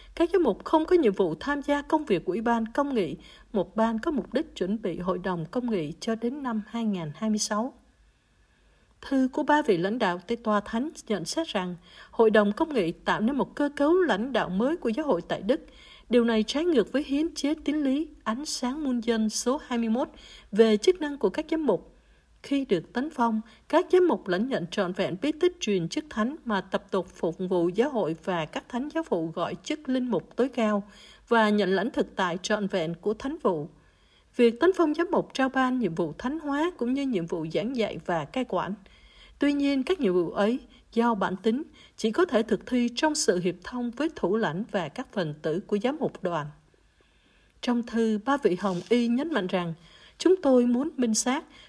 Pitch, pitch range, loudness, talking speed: 230 Hz, 195-280 Hz, -27 LUFS, 220 wpm